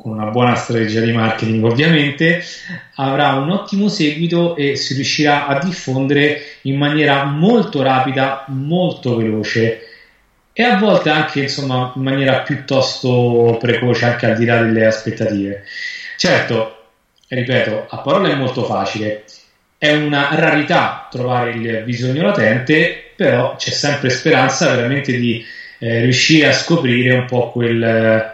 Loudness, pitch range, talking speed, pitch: -15 LUFS, 115-150 Hz, 135 wpm, 130 Hz